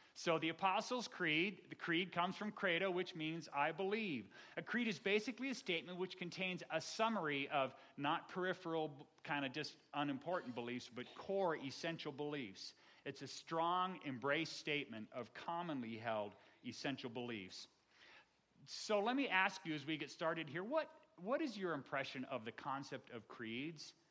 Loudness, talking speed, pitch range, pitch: -42 LUFS, 160 wpm, 140-185 Hz, 160 Hz